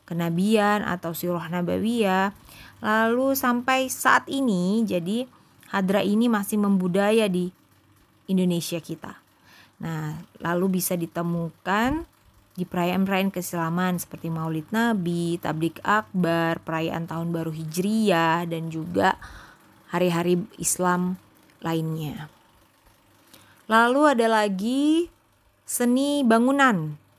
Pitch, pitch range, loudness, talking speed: 180 Hz, 165-220 Hz, -24 LUFS, 95 wpm